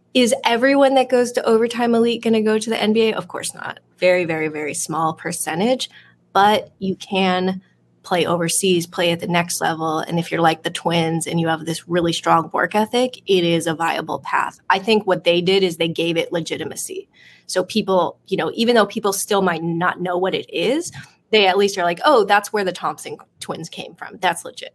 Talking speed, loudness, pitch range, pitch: 215 wpm, -19 LUFS, 170-225 Hz, 185 Hz